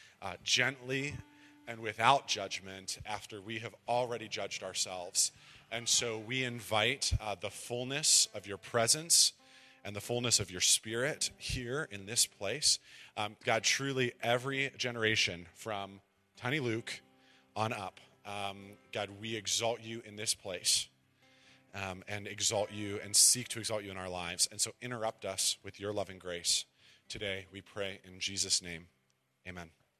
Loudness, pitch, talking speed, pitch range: -32 LUFS, 105 Hz, 150 wpm, 95-120 Hz